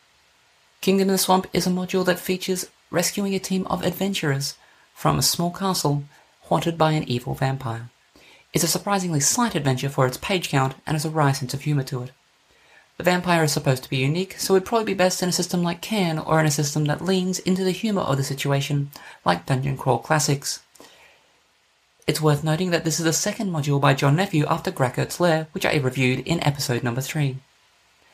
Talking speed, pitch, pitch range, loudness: 205 wpm, 155 Hz, 140-185 Hz, -23 LUFS